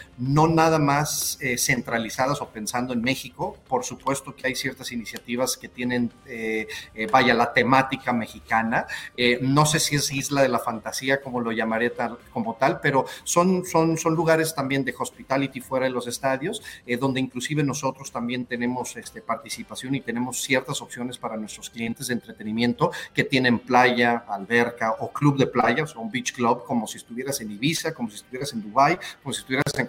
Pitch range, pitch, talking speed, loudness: 120-135 Hz, 130 Hz, 185 wpm, -24 LUFS